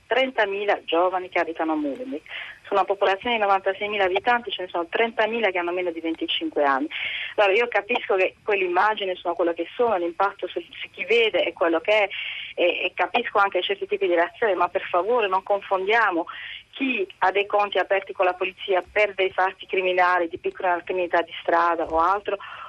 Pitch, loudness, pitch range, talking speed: 190 Hz, -23 LUFS, 180-210 Hz, 195 wpm